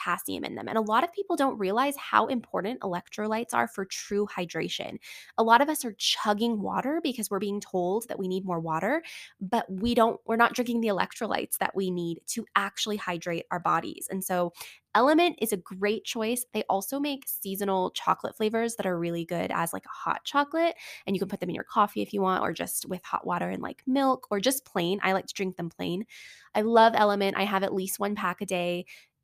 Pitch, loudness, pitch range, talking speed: 205 Hz, -28 LUFS, 190-235 Hz, 225 wpm